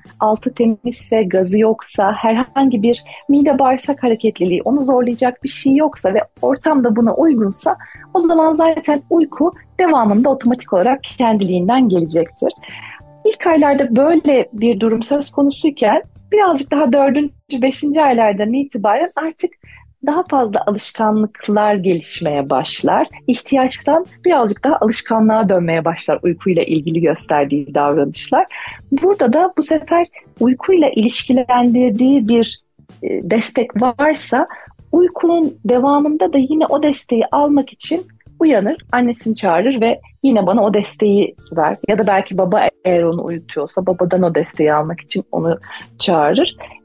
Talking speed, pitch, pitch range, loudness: 125 wpm, 245 Hz, 210-290 Hz, -15 LUFS